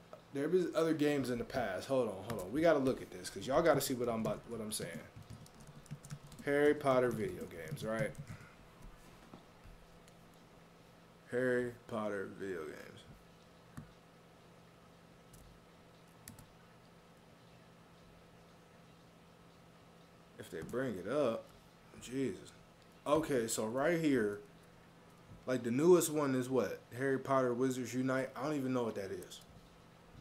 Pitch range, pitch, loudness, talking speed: 120-145 Hz, 130 Hz, -36 LUFS, 125 wpm